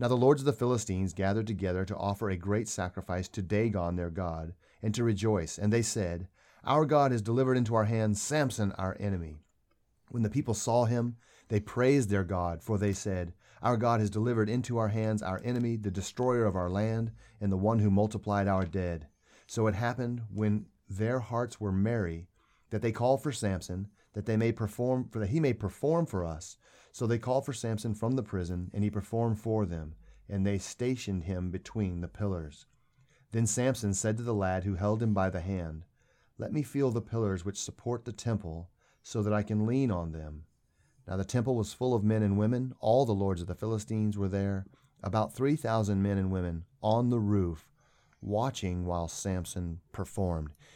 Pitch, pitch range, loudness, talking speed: 105 Hz, 95-120 Hz, -31 LUFS, 200 wpm